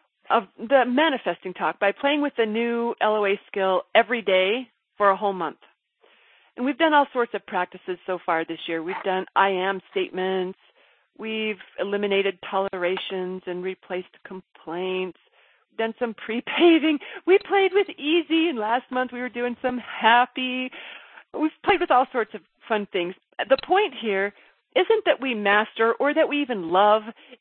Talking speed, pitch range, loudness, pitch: 165 wpm, 190-270 Hz, -23 LUFS, 225 Hz